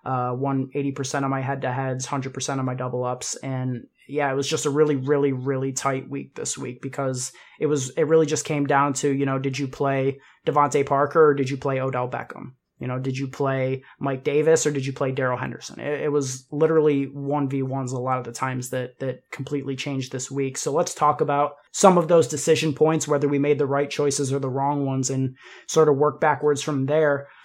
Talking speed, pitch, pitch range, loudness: 225 wpm, 140 Hz, 130-145 Hz, -23 LUFS